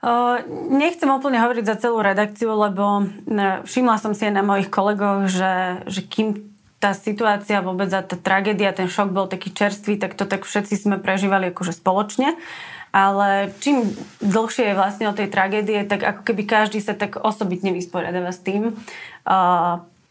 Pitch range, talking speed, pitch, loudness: 195-215 Hz, 165 wpm, 205 Hz, -20 LUFS